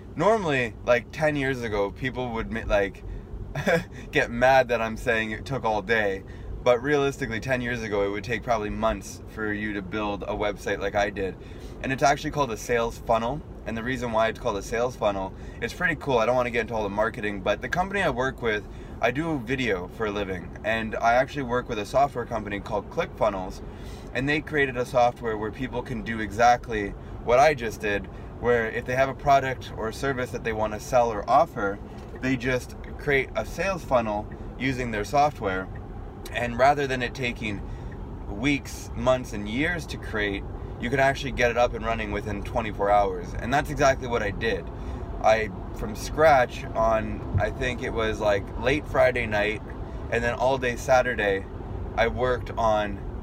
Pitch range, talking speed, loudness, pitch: 105-125 Hz, 195 wpm, -26 LUFS, 115 Hz